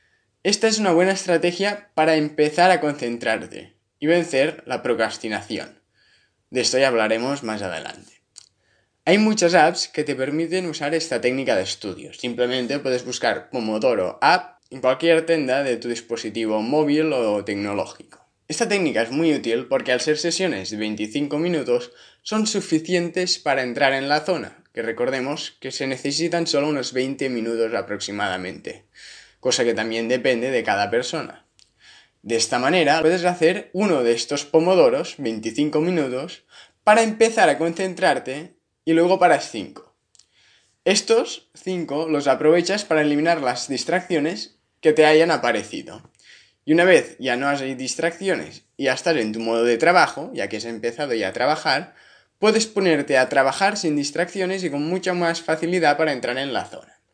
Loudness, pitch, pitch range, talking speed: -21 LUFS, 150 Hz, 125-175 Hz, 155 wpm